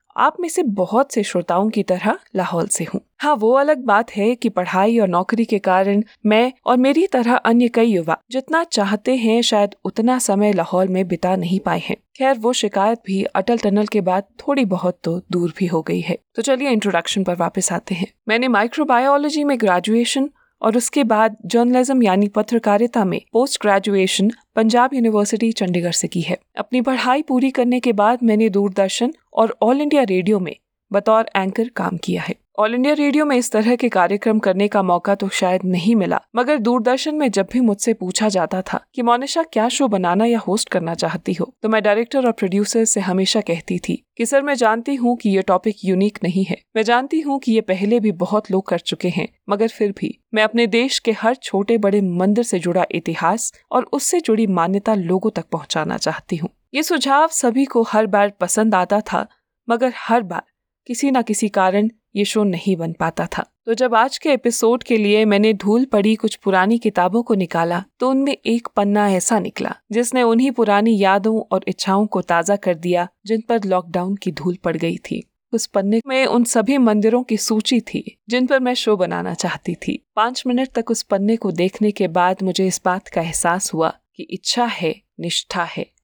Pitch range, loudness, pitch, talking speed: 190-240 Hz, -18 LUFS, 220 Hz, 200 wpm